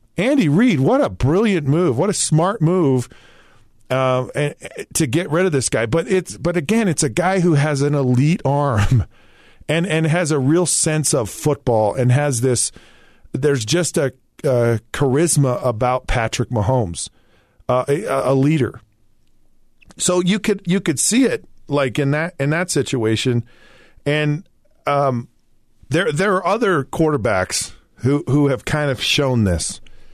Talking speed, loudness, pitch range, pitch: 160 wpm, -18 LUFS, 125-165 Hz, 140 Hz